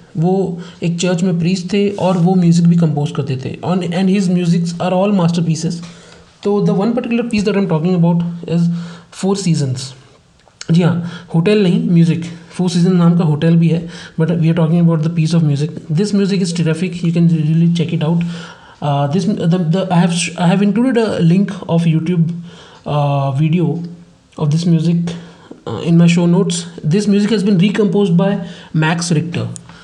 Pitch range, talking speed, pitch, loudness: 165-185 Hz, 170 wpm, 170 Hz, -15 LUFS